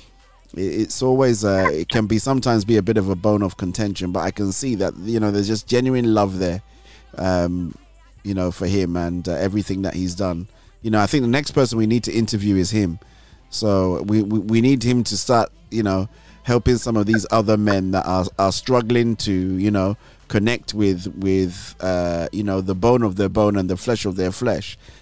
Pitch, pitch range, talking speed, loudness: 105 Hz, 95-115 Hz, 220 wpm, -20 LUFS